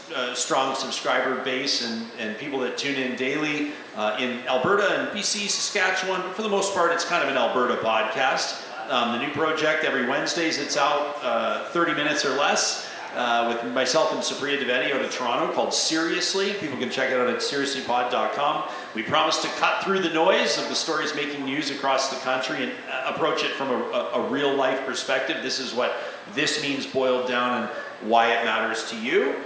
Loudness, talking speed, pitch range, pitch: -24 LUFS, 195 wpm, 125-160 Hz, 135 Hz